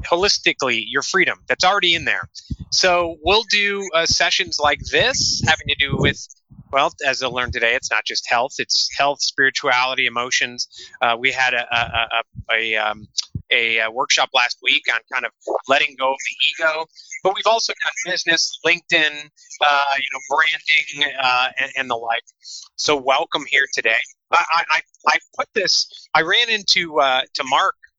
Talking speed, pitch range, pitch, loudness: 170 wpm, 125-165 Hz, 140 Hz, -18 LUFS